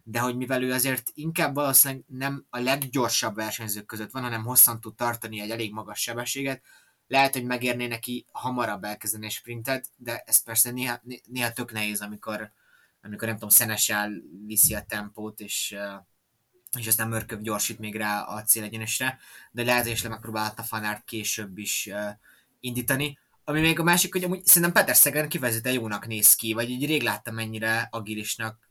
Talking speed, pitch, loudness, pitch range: 165 wpm, 115 Hz, -24 LUFS, 110-130 Hz